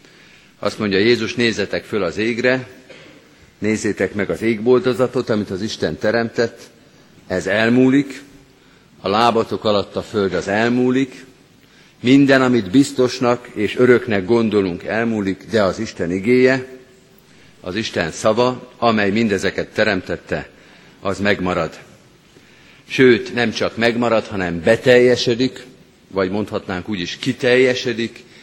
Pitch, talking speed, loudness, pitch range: 115 Hz, 115 wpm, -18 LUFS, 105-125 Hz